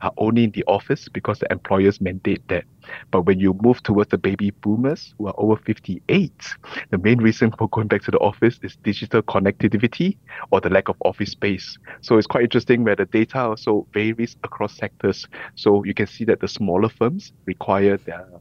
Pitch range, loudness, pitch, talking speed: 100-115 Hz, -20 LUFS, 110 Hz, 200 wpm